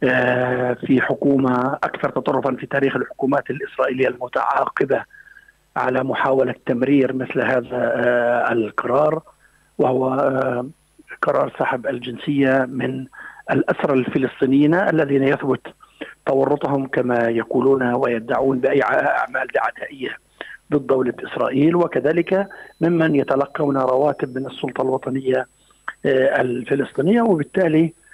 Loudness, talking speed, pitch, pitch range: -20 LUFS, 90 wpm, 135 Hz, 130-145 Hz